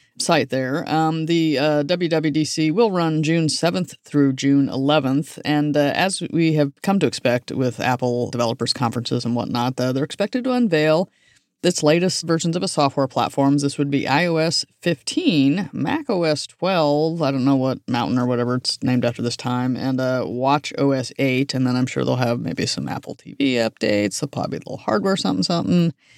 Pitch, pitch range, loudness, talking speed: 145 Hz, 130-165 Hz, -20 LUFS, 185 wpm